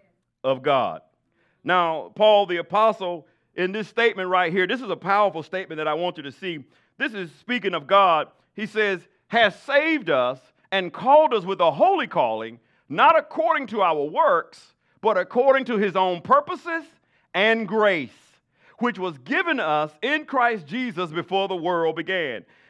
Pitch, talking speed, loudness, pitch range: 195 Hz, 165 wpm, -22 LUFS, 170-235 Hz